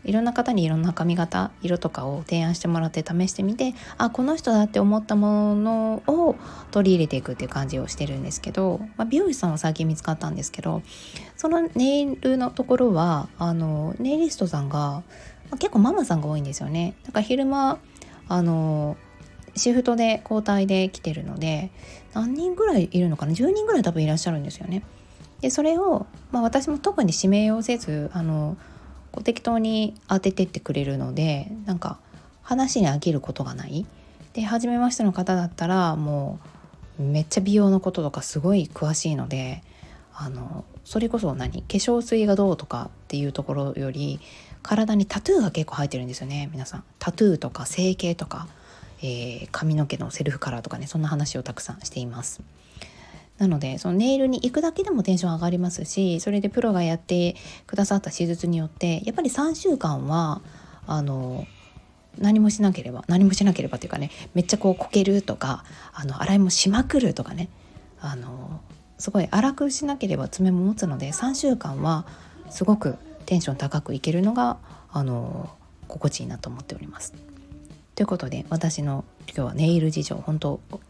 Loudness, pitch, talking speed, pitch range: -24 LUFS, 180 Hz, 360 characters per minute, 155-215 Hz